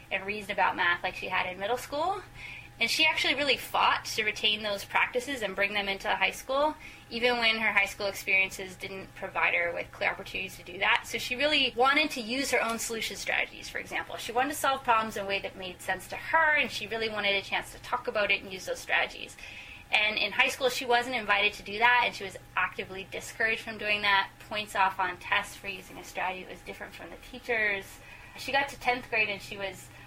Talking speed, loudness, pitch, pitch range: 235 wpm, -28 LUFS, 215 Hz, 195-250 Hz